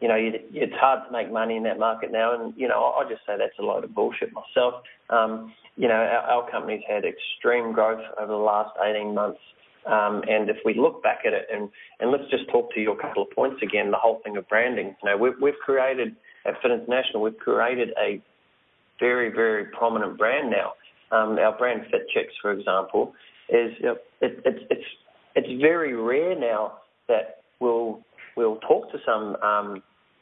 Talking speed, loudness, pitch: 200 wpm, -24 LUFS, 115 Hz